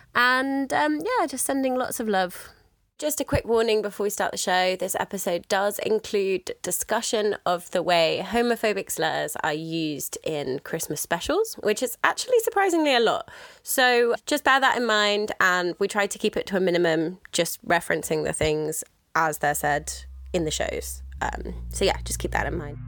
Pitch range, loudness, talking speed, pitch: 170-260 Hz, -24 LUFS, 185 wpm, 205 Hz